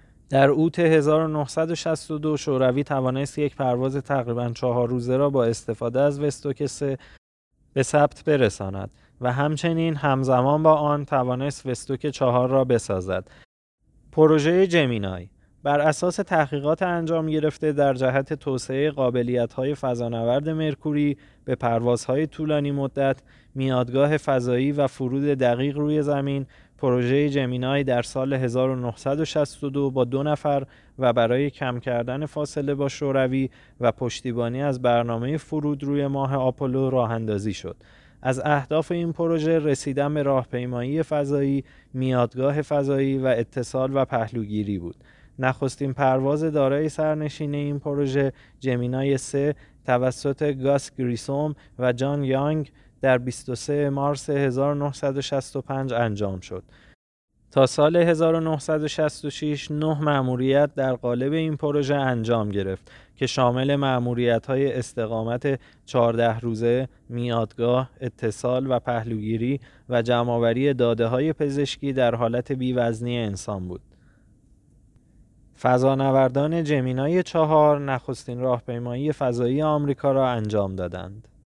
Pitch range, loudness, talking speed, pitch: 120-145 Hz, -23 LUFS, 115 wpm, 135 Hz